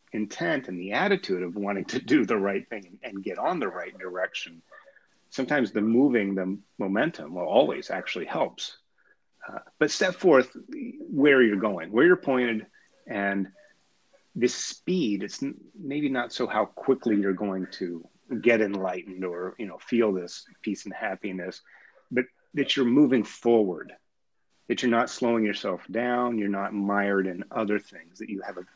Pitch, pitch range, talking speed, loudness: 105 Hz, 95-125 Hz, 165 wpm, -26 LUFS